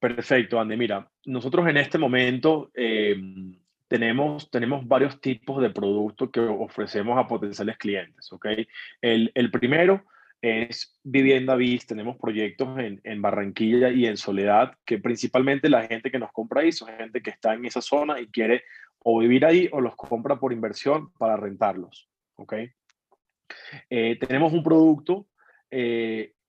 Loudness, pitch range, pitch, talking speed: -24 LUFS, 110-135 Hz, 120 Hz, 150 wpm